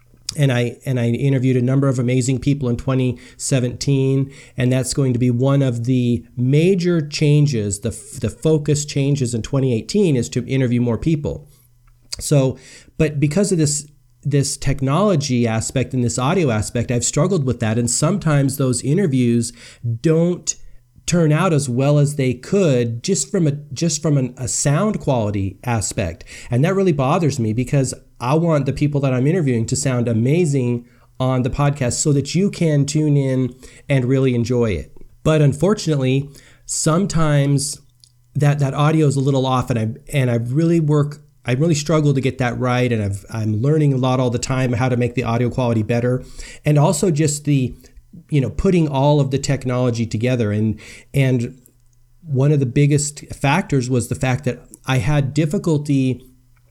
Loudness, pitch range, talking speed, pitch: -18 LUFS, 120-145 Hz, 175 wpm, 130 Hz